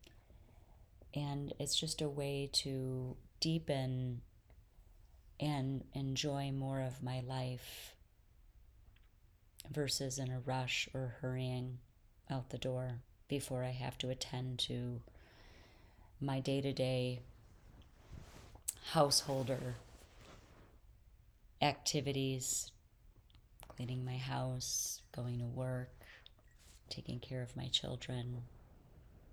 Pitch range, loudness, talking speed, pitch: 110-135 Hz, -40 LUFS, 90 wpm, 125 Hz